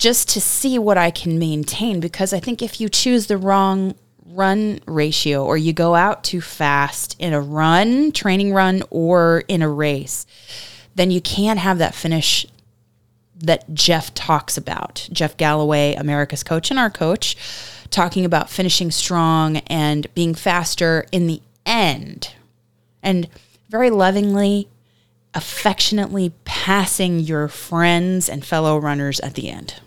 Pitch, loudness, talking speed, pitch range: 170 Hz, -18 LUFS, 145 wpm, 150-195 Hz